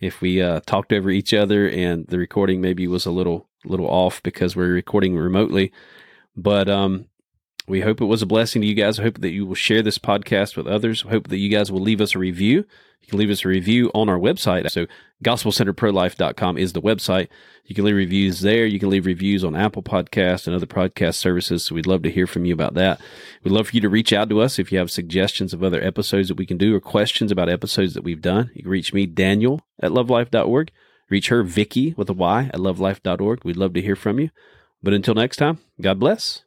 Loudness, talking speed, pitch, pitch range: -20 LUFS, 235 wpm, 100 Hz, 90-105 Hz